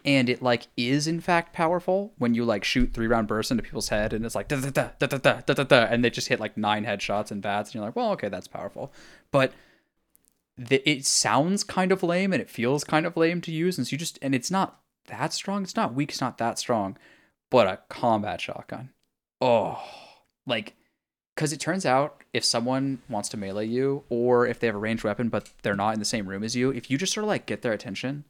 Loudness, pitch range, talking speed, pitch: -26 LUFS, 115-155 Hz, 245 wpm, 130 Hz